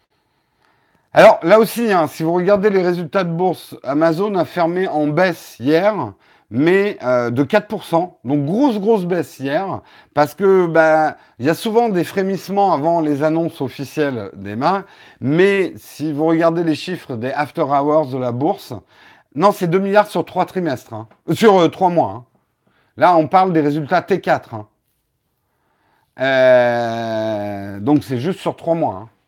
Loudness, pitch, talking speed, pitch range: -17 LUFS, 165 Hz, 165 wpm, 140-185 Hz